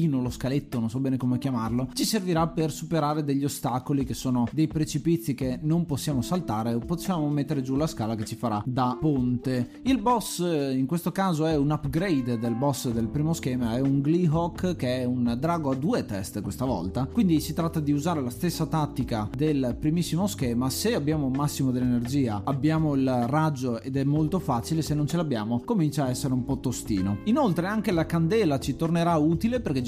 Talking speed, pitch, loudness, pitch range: 195 wpm, 140 Hz, -26 LUFS, 125-160 Hz